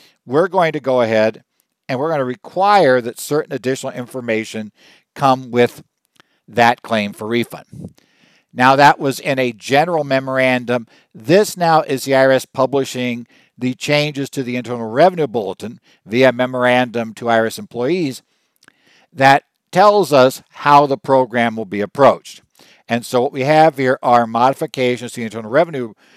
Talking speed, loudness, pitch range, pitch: 150 wpm, -16 LUFS, 120-140 Hz, 130 Hz